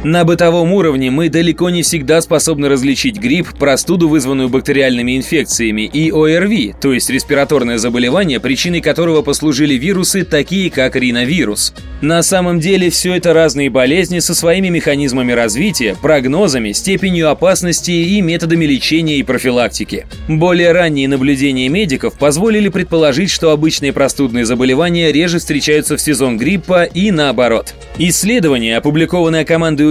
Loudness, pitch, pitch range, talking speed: -12 LUFS, 155 Hz, 135-170 Hz, 130 wpm